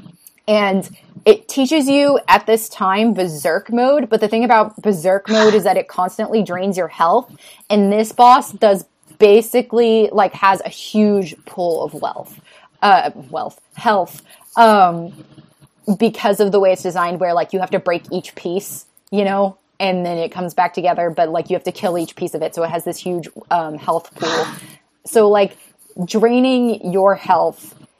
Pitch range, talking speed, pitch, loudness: 180-220 Hz, 180 wpm, 195 Hz, -16 LUFS